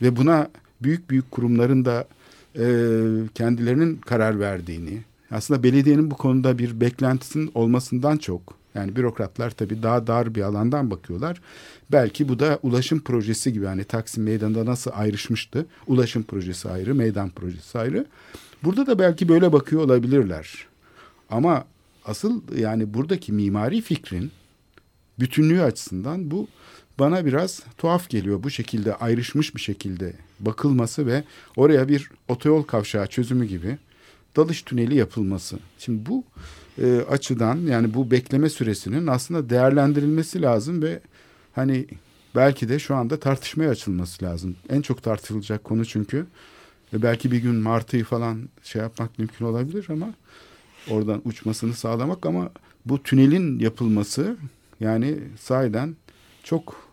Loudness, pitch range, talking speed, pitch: -23 LUFS, 110-140 Hz, 130 wpm, 120 Hz